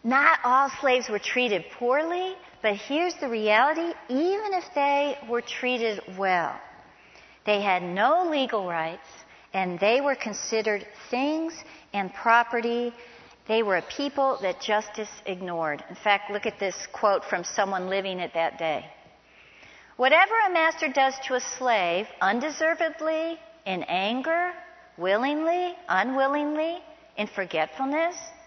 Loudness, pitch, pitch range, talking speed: -26 LUFS, 245 Hz, 200-315 Hz, 130 wpm